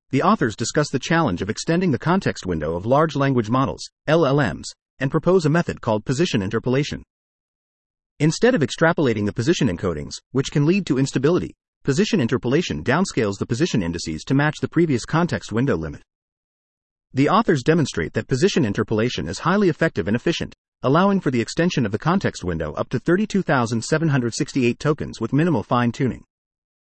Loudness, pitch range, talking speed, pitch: -21 LUFS, 110-165 Hz, 165 wpm, 135 Hz